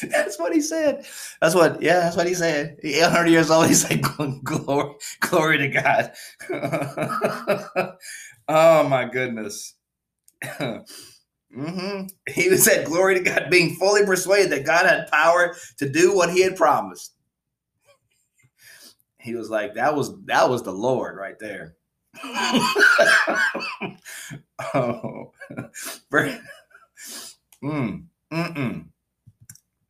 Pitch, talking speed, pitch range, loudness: 165 Hz, 110 wpm, 145-185 Hz, -20 LUFS